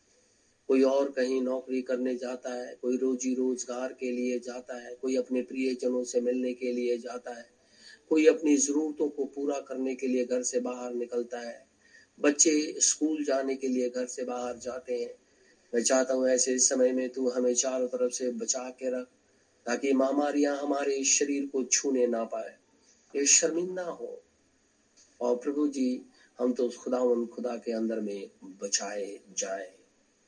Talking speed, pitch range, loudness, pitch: 165 wpm, 125-135 Hz, -29 LUFS, 130 Hz